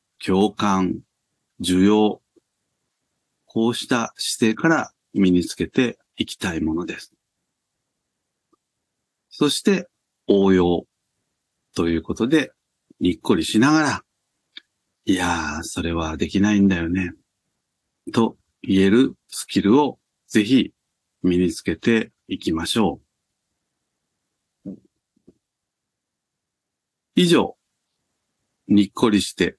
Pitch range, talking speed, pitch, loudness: 90-105 Hz, 175 characters per minute, 95 Hz, -21 LUFS